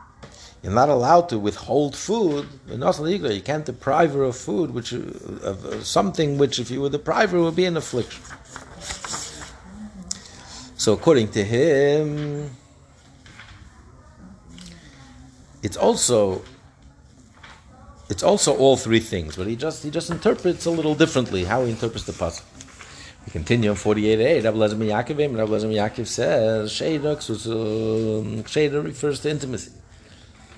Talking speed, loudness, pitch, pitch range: 130 wpm, -22 LUFS, 125 Hz, 110-150 Hz